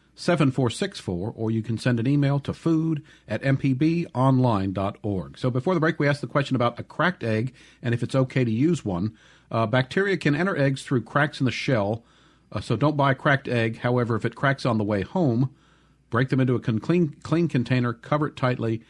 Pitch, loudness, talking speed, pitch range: 130 Hz, -24 LUFS, 205 wpm, 115-150 Hz